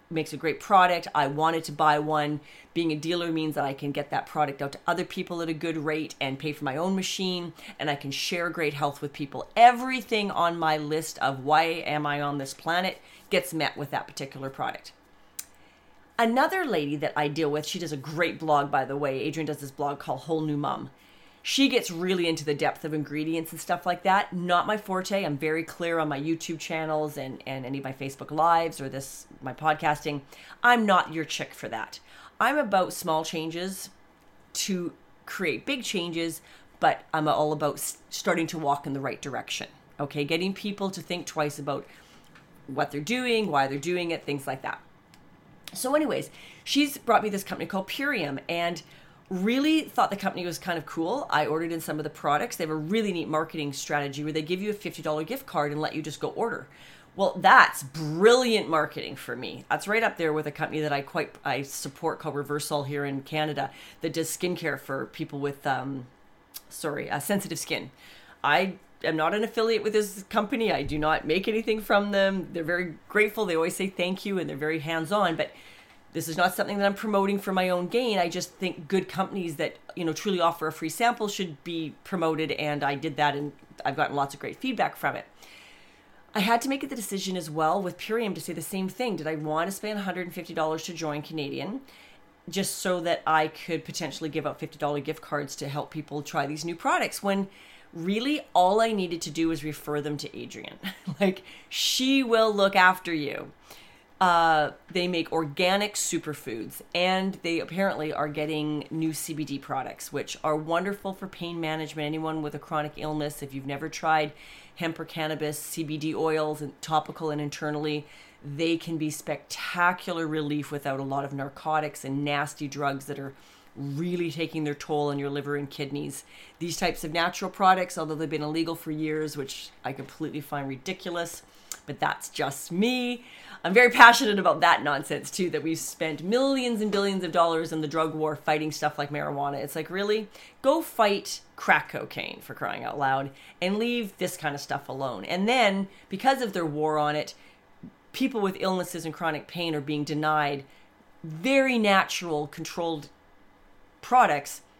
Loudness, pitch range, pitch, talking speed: -27 LUFS, 150-185 Hz, 160 Hz, 195 wpm